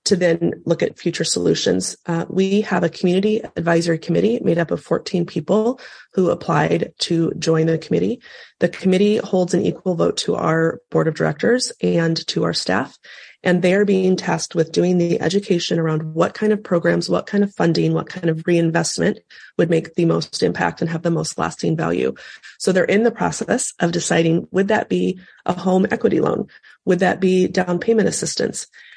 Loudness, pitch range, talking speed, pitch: -19 LUFS, 165-190 Hz, 190 wpm, 175 Hz